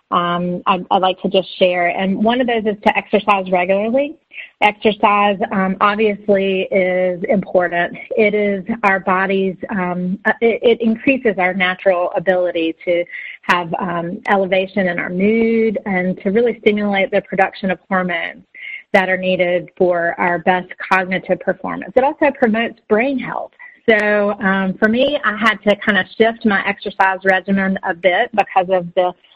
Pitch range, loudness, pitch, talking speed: 185-220 Hz, -16 LUFS, 195 Hz, 155 wpm